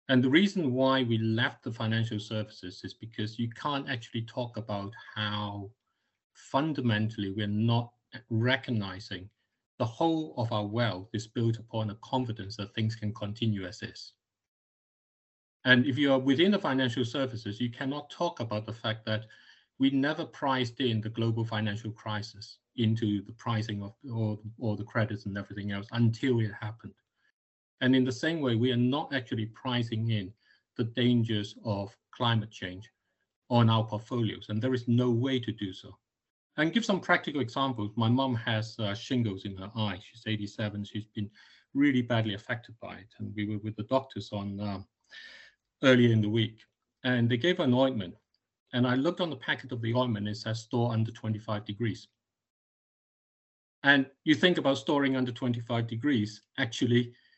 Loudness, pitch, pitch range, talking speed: -30 LUFS, 115 Hz, 105-130 Hz, 170 wpm